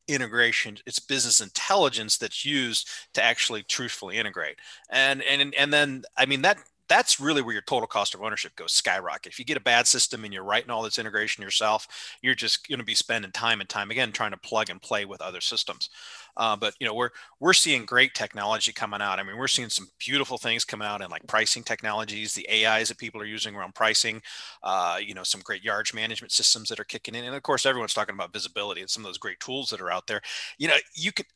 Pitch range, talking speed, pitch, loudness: 110-135 Hz, 235 wpm, 115 Hz, -25 LUFS